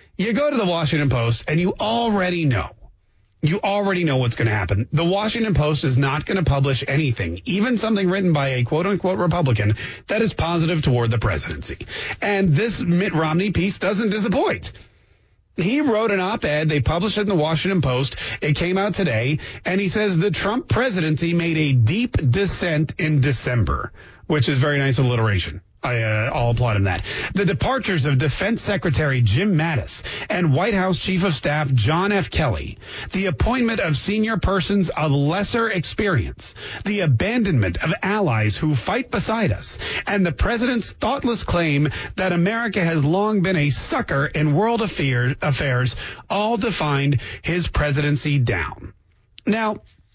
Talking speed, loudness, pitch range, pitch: 170 wpm, -20 LUFS, 125-195 Hz, 155 Hz